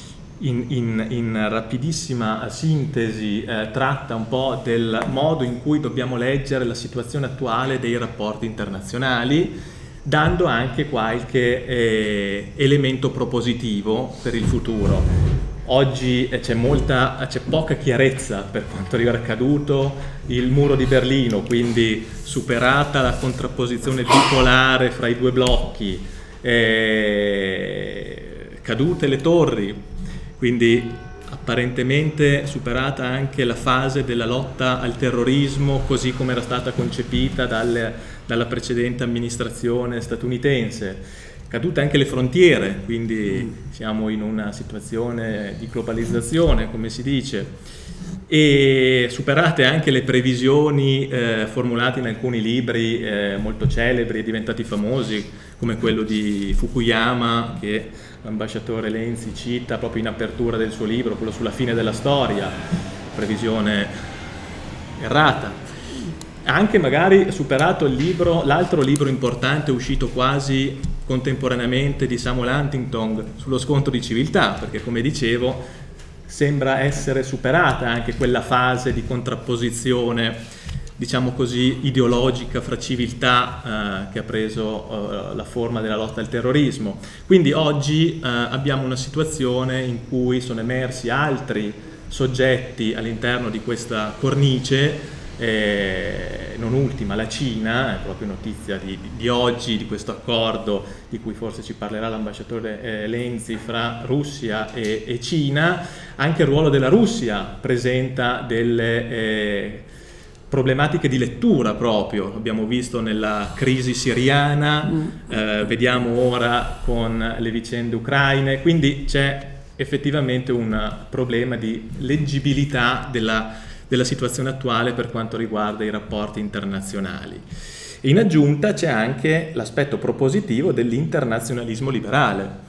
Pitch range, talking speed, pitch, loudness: 110-135 Hz, 120 wpm, 120 Hz, -21 LUFS